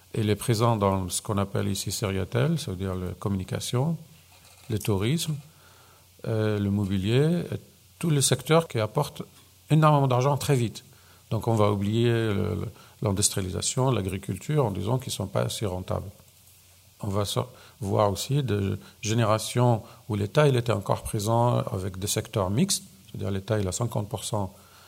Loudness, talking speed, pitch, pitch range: -26 LUFS, 150 wpm, 110 Hz, 100-125 Hz